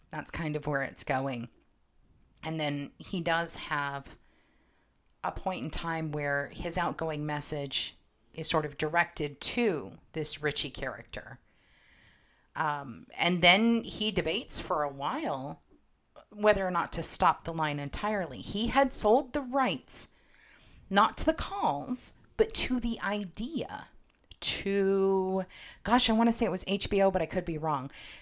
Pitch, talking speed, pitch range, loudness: 170 Hz, 150 wpm, 150-210 Hz, -29 LUFS